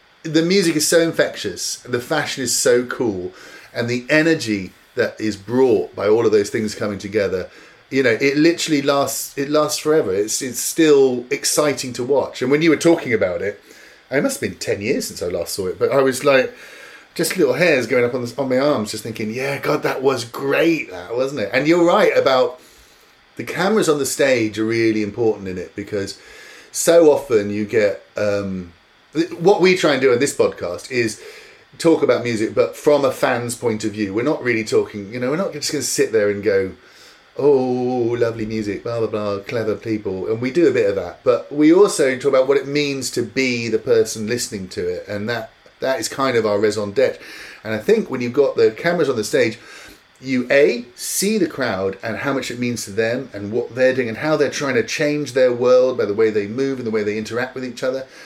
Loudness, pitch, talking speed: -19 LUFS, 135 Hz, 225 wpm